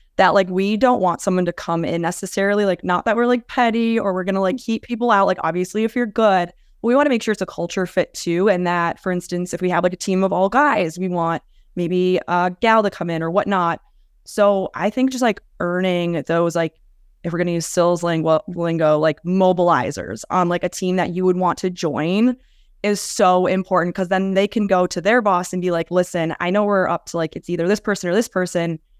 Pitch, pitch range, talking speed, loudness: 185 Hz, 175-205 Hz, 245 wpm, -19 LUFS